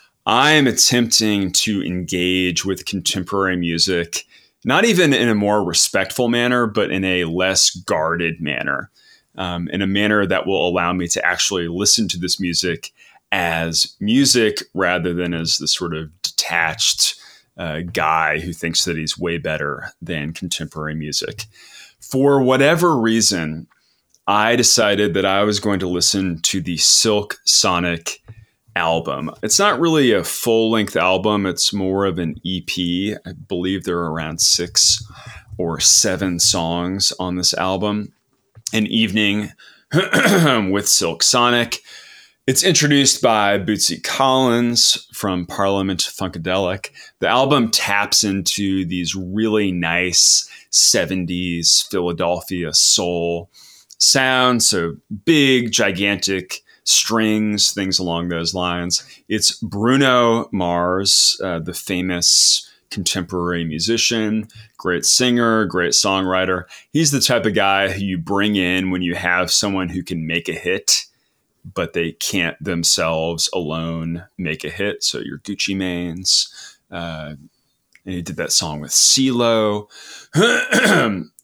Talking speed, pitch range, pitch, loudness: 130 wpm, 85-110 Hz, 95 Hz, -17 LUFS